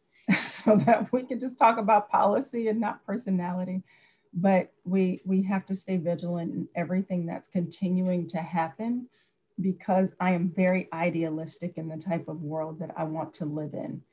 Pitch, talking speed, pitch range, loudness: 185 Hz, 170 wpm, 165-195 Hz, -28 LUFS